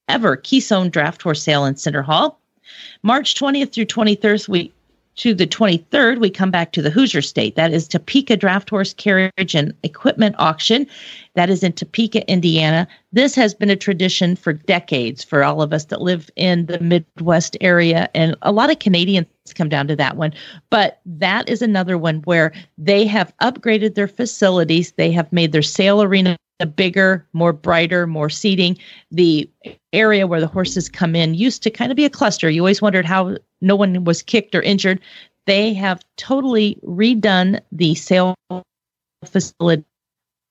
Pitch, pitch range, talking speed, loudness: 185 Hz, 165-210 Hz, 175 wpm, -16 LUFS